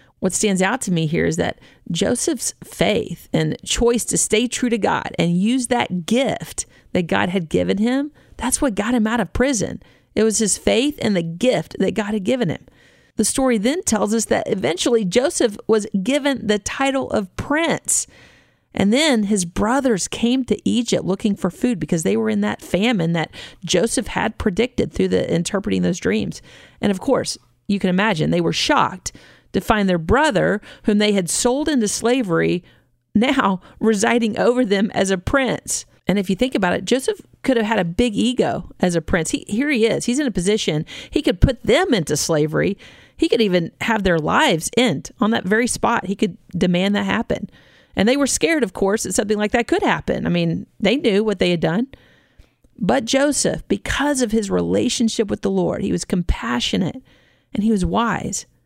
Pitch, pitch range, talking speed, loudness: 220 Hz, 190-245 Hz, 195 wpm, -19 LUFS